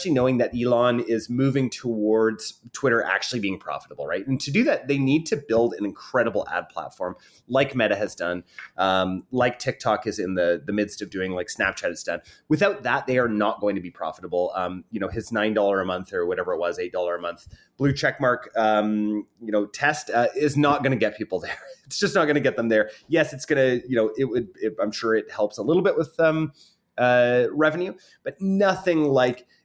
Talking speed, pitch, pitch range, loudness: 225 wpm, 120 Hz, 105-140 Hz, -24 LUFS